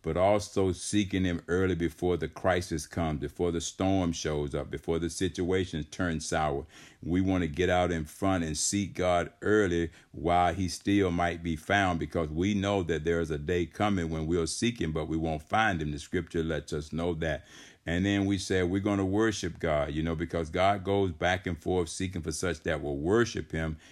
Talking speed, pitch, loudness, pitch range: 210 wpm, 85 Hz, -30 LUFS, 80-95 Hz